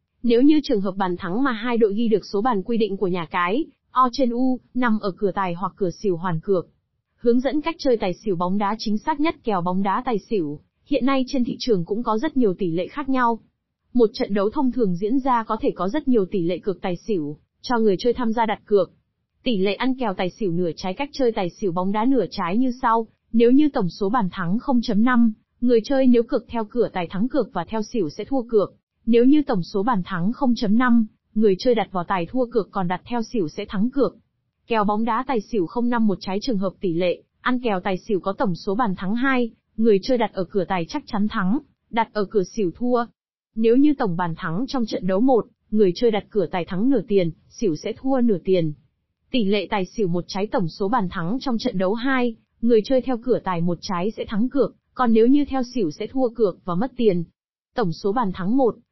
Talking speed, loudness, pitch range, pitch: 245 wpm, -22 LUFS, 190-245 Hz, 220 Hz